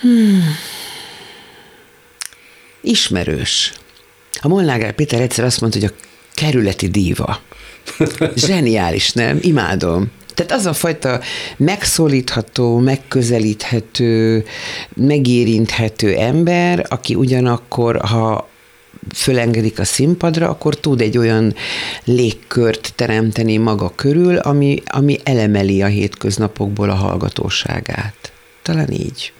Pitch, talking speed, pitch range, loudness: 120 Hz, 95 wpm, 110-150 Hz, -15 LUFS